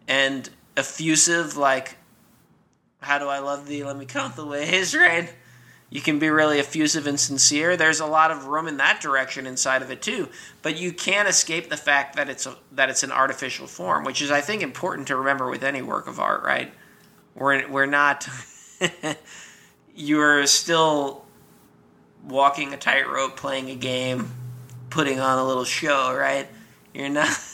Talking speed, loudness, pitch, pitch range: 170 wpm, -22 LUFS, 140 Hz, 130-155 Hz